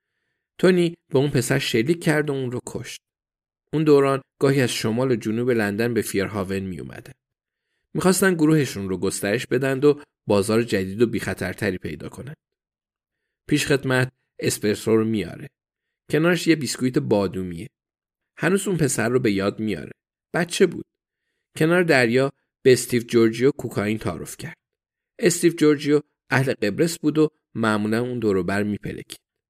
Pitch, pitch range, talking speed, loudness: 125 Hz, 105-150 Hz, 145 wpm, -22 LUFS